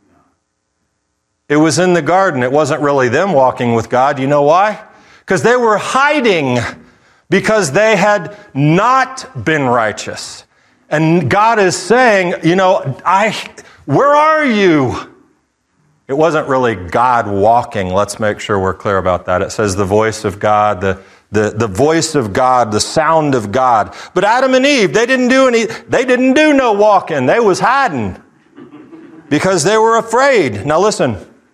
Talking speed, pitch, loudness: 160 wpm, 160 Hz, -12 LUFS